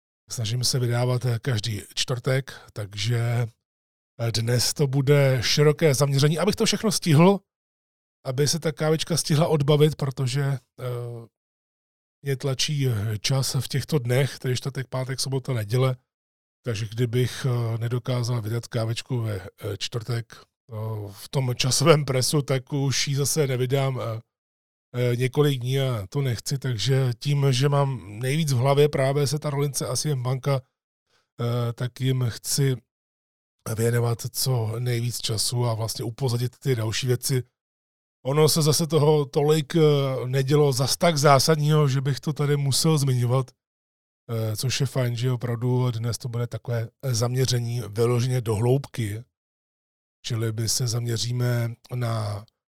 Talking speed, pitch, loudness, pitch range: 130 wpm, 125 Hz, -24 LUFS, 115-140 Hz